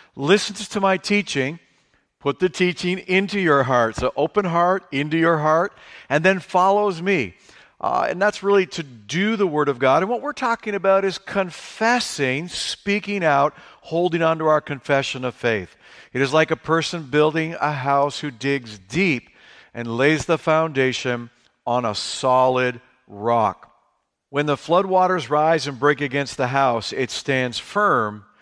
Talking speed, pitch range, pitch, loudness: 165 wpm, 135-185 Hz, 155 Hz, -21 LUFS